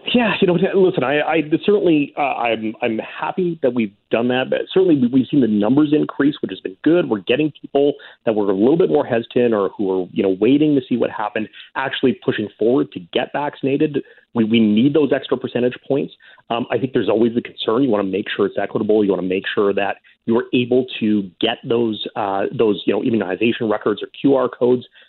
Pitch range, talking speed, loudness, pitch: 110-155 Hz, 225 wpm, -18 LUFS, 125 Hz